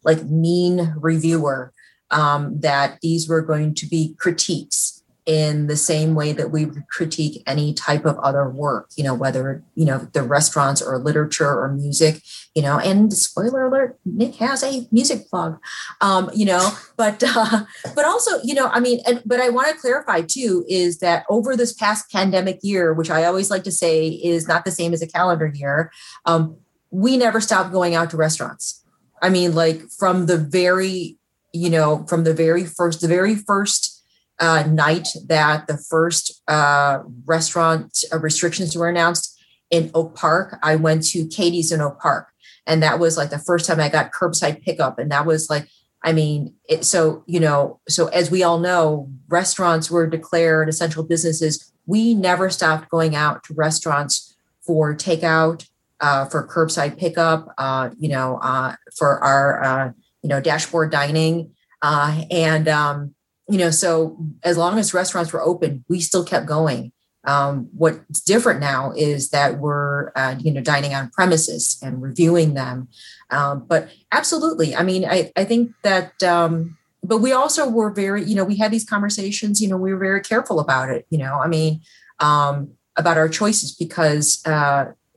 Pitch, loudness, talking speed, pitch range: 165 Hz, -19 LUFS, 180 wpm, 150-180 Hz